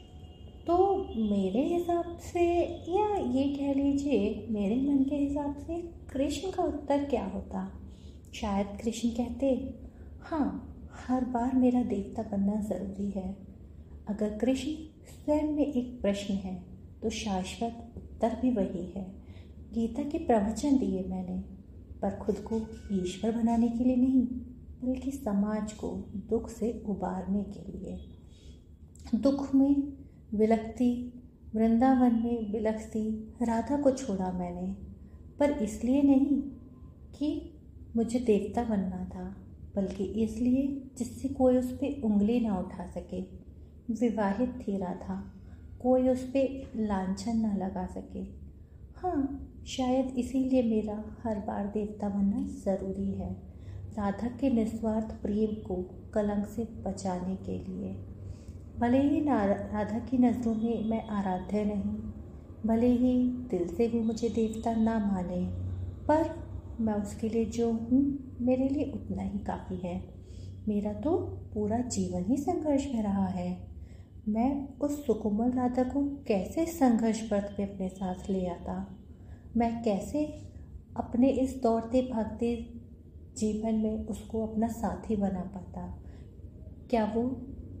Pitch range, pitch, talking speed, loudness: 190-255 Hz, 220 Hz, 130 wpm, -31 LUFS